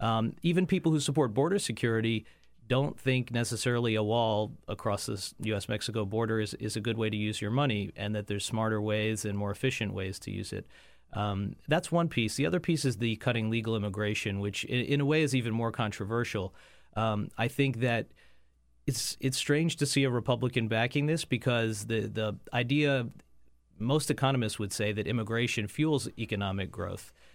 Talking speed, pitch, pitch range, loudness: 185 wpm, 115 Hz, 105-130 Hz, -31 LUFS